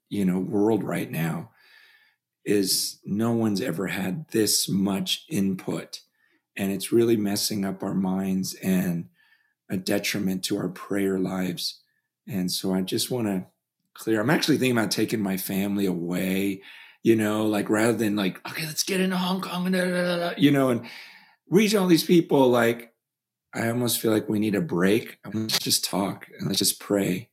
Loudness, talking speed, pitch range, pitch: -25 LUFS, 175 wpm, 95-130 Hz, 105 Hz